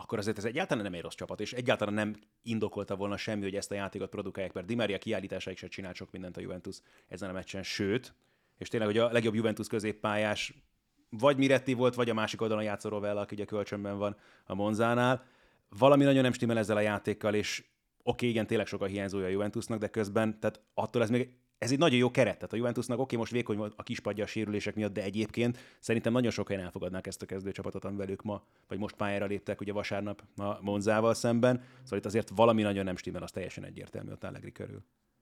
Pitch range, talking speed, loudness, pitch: 100-115 Hz, 220 wpm, -32 LUFS, 105 Hz